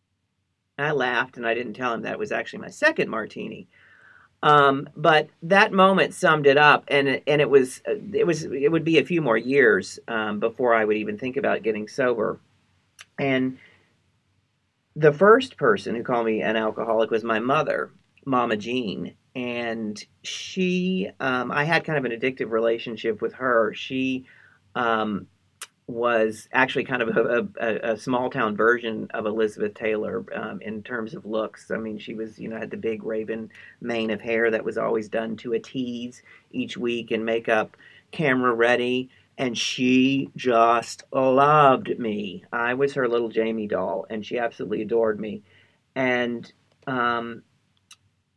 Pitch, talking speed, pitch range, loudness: 120 Hz, 165 wpm, 110-135 Hz, -23 LUFS